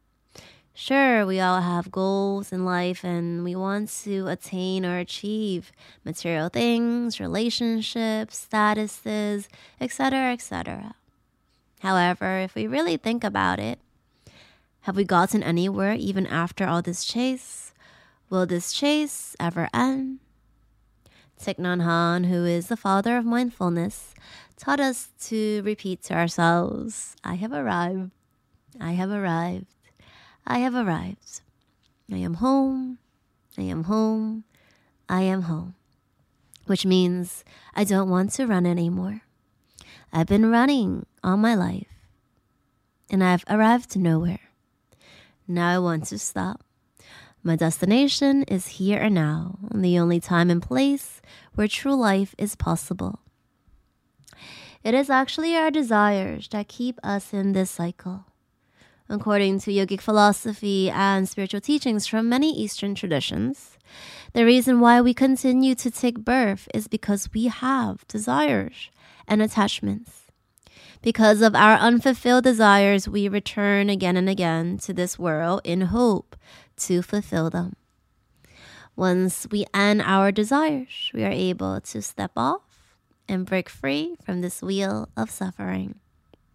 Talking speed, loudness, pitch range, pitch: 130 wpm, -23 LUFS, 175-225 Hz, 195 Hz